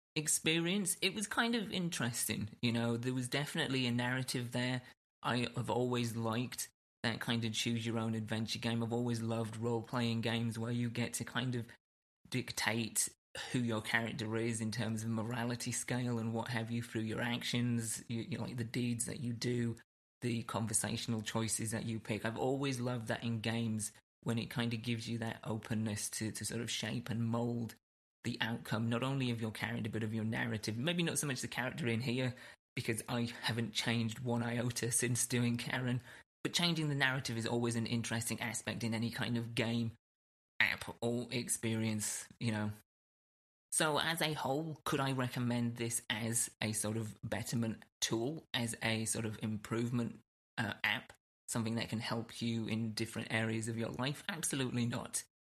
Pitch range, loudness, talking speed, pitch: 115-125 Hz, -37 LUFS, 185 wpm, 115 Hz